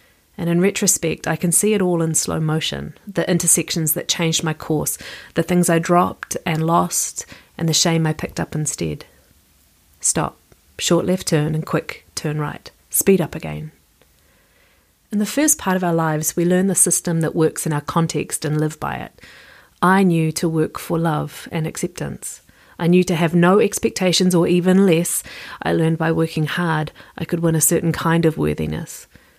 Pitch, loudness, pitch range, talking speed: 165 Hz, -19 LUFS, 155-175 Hz, 185 wpm